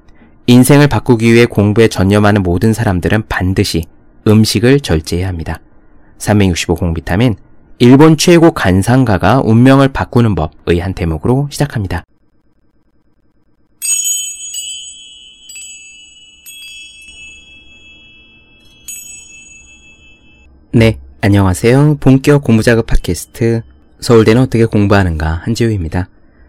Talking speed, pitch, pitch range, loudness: 220 characters per minute, 105 Hz, 80-115 Hz, -11 LUFS